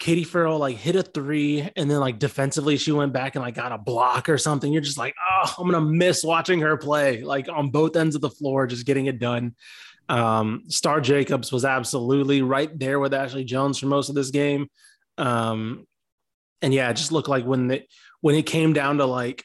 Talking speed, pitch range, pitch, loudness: 220 wpm, 130-155 Hz, 140 Hz, -23 LUFS